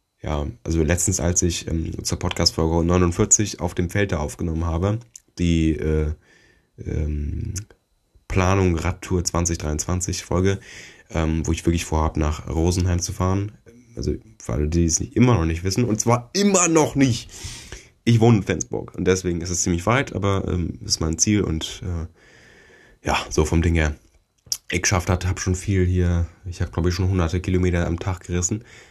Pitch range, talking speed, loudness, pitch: 85-100 Hz, 175 wpm, -22 LUFS, 90 Hz